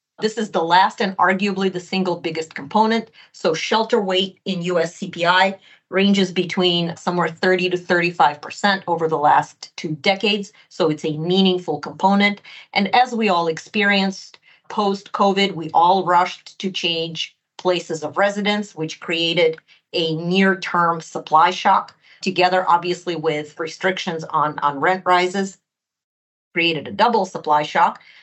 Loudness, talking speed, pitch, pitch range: -19 LUFS, 145 wpm, 180 Hz, 165-195 Hz